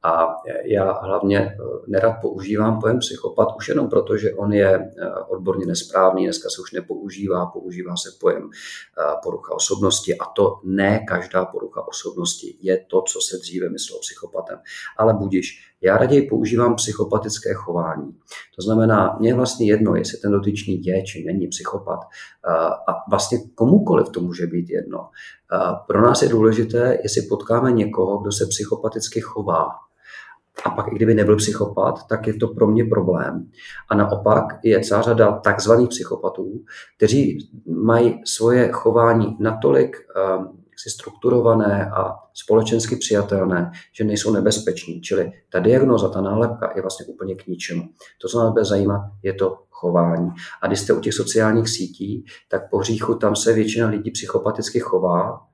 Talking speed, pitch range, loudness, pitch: 155 wpm, 95-115 Hz, -20 LUFS, 110 Hz